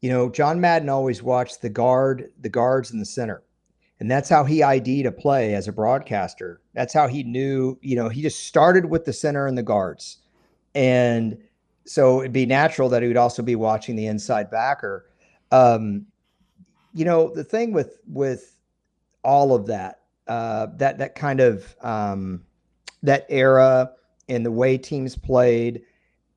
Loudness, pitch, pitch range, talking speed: -21 LUFS, 130 Hz, 120-140 Hz, 170 wpm